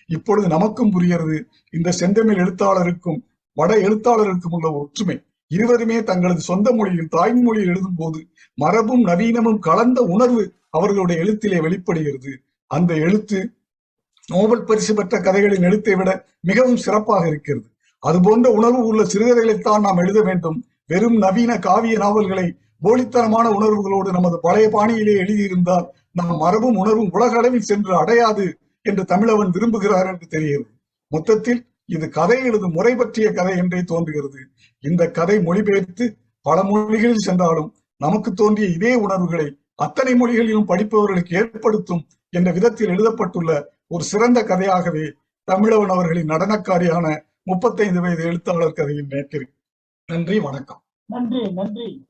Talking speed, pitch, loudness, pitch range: 120 wpm, 195 Hz, -18 LUFS, 170-220 Hz